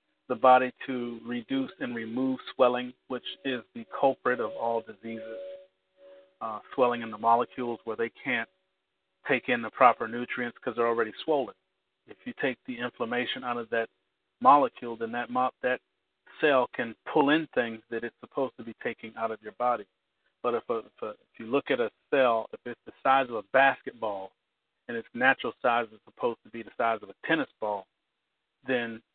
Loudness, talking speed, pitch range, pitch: -29 LUFS, 190 wpm, 115-130 Hz, 120 Hz